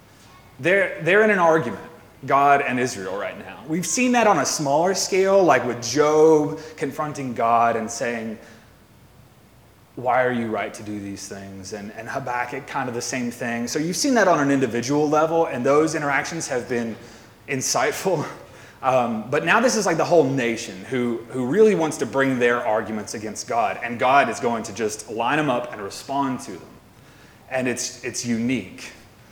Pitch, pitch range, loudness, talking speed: 125 Hz, 115-155 Hz, -21 LUFS, 185 wpm